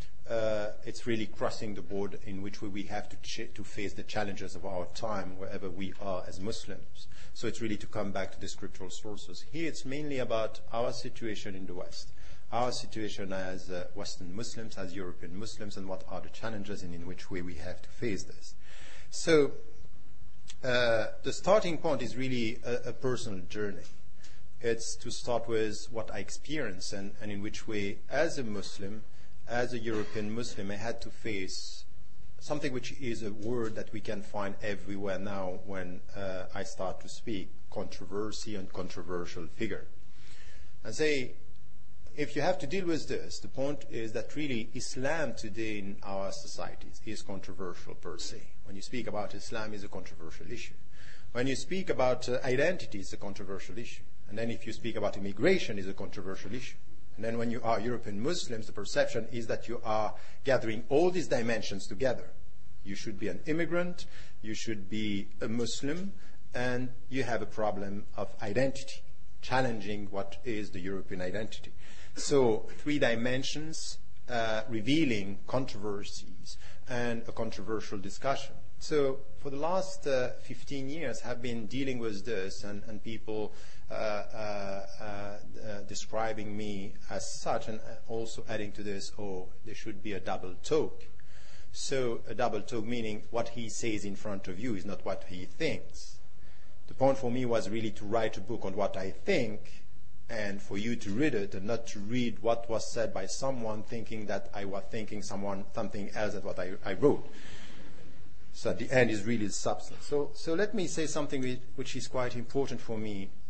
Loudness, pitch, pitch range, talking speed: -35 LUFS, 110 Hz, 100-120 Hz, 180 wpm